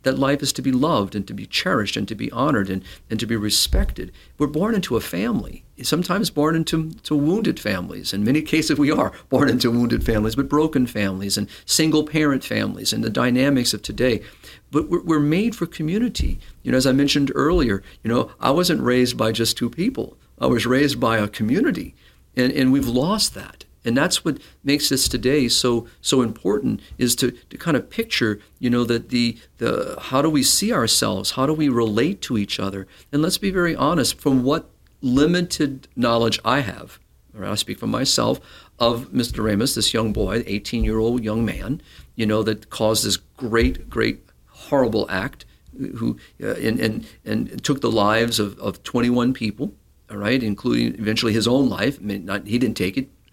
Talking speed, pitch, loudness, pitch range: 195 wpm, 120 Hz, -21 LUFS, 110-145 Hz